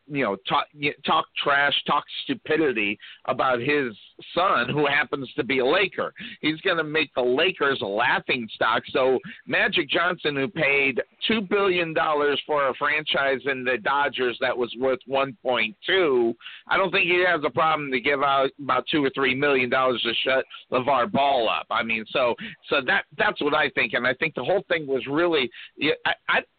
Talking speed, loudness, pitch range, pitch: 190 wpm, -23 LUFS, 130-155 Hz, 140 Hz